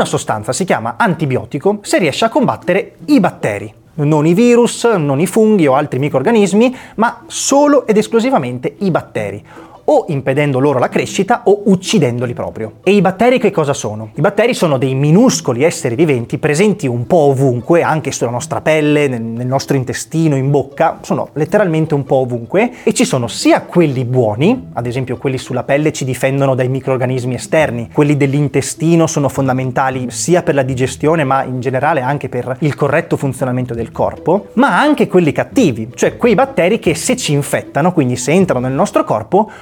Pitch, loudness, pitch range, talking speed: 145 Hz, -14 LUFS, 130-190 Hz, 175 wpm